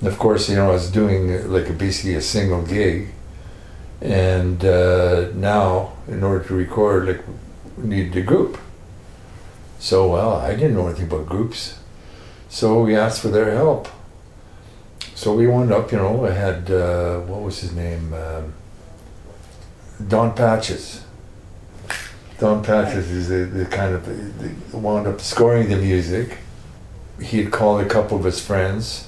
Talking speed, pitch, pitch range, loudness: 155 wpm, 95 Hz, 90-105 Hz, -19 LUFS